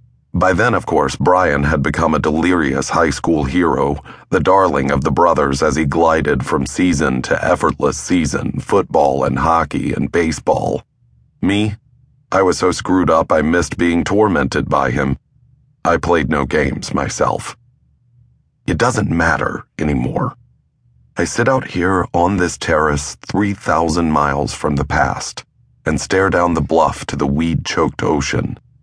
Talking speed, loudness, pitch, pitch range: 150 wpm, -16 LUFS, 80 Hz, 70-100 Hz